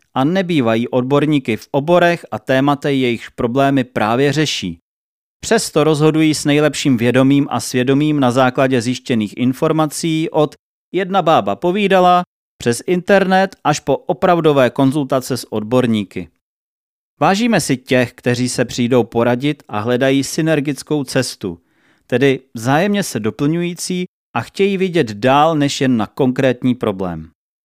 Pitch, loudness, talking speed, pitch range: 135 Hz, -16 LUFS, 125 wpm, 125-155 Hz